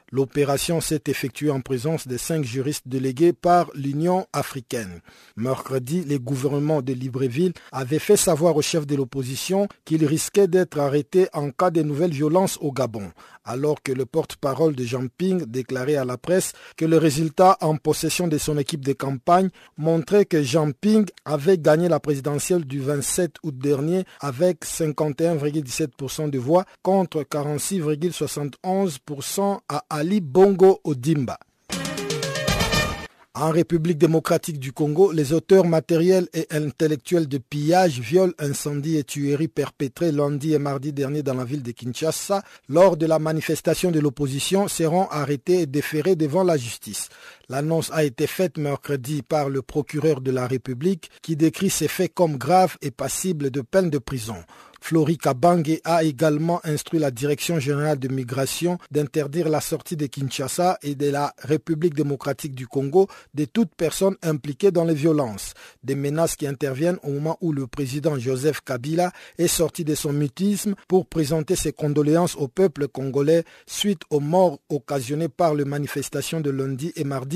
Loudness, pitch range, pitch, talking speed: -22 LUFS, 140-170 Hz, 155 Hz, 155 wpm